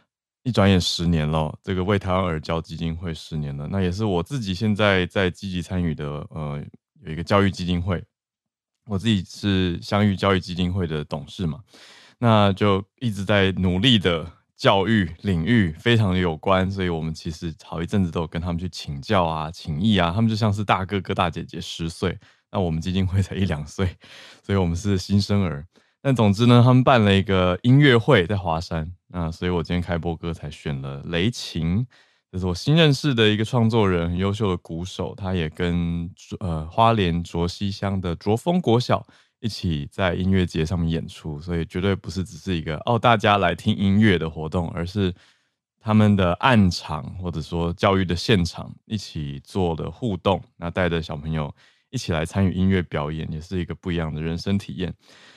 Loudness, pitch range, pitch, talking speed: -22 LUFS, 85-105 Hz, 90 Hz, 290 characters per minute